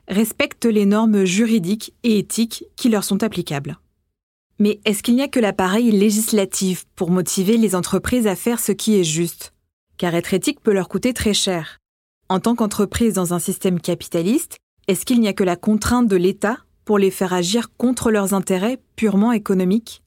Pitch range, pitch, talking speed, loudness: 185-225 Hz, 205 Hz, 180 wpm, -19 LUFS